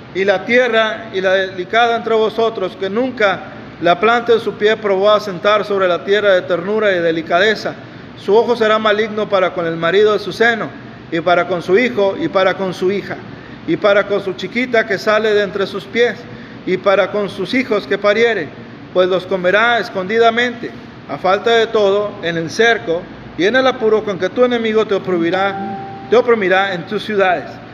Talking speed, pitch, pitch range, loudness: 195 wpm, 200 Hz, 185-220 Hz, -15 LUFS